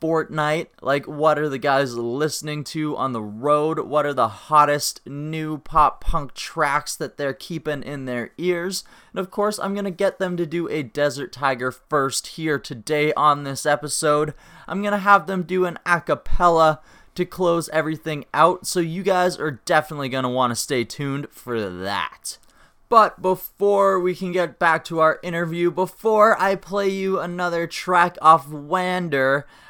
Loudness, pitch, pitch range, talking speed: -21 LUFS, 160 Hz, 145-180 Hz, 170 wpm